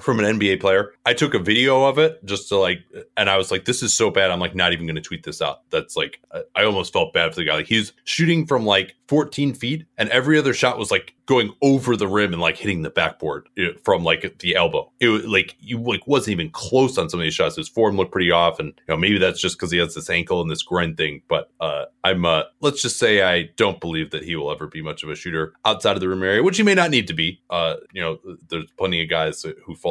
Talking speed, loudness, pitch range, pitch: 275 wpm, -20 LUFS, 95-145 Hz, 110 Hz